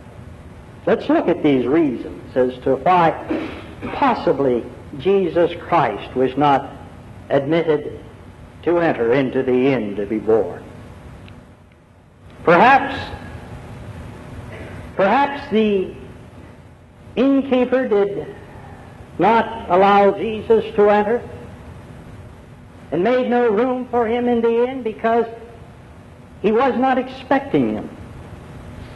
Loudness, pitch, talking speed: -18 LUFS, 180 Hz, 95 wpm